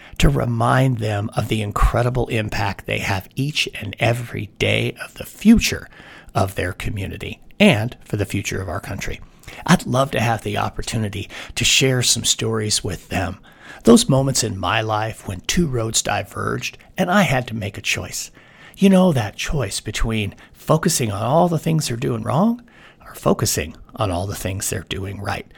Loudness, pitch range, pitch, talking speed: -20 LUFS, 105-130 Hz, 115 Hz, 180 wpm